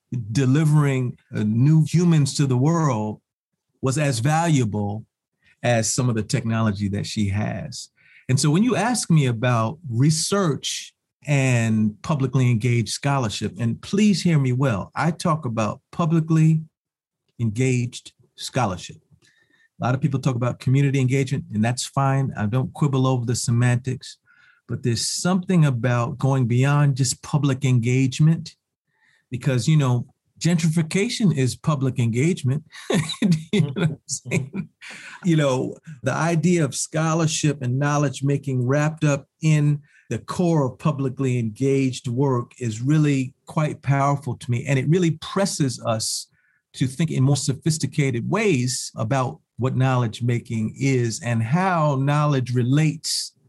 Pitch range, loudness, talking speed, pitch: 125-155 Hz, -22 LUFS, 135 wpm, 135 Hz